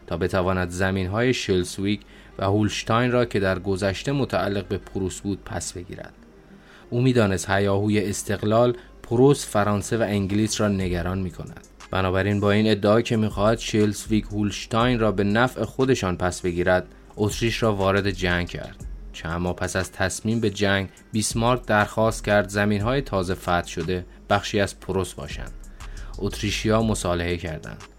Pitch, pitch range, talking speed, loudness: 100 Hz, 95-110 Hz, 150 wpm, -23 LUFS